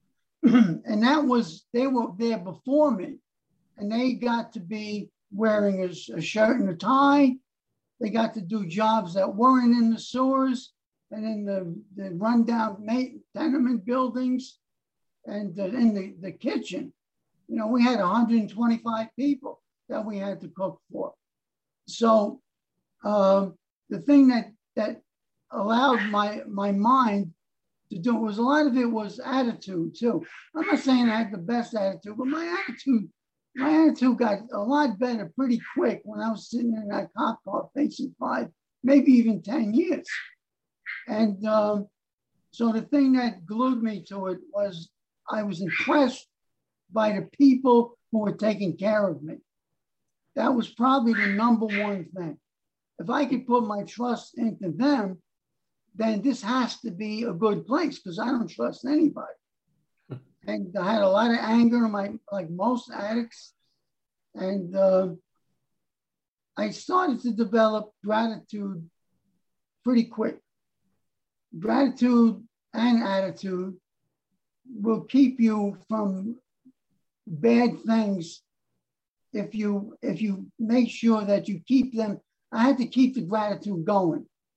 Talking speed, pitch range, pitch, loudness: 145 wpm, 200-250 Hz, 225 Hz, -25 LUFS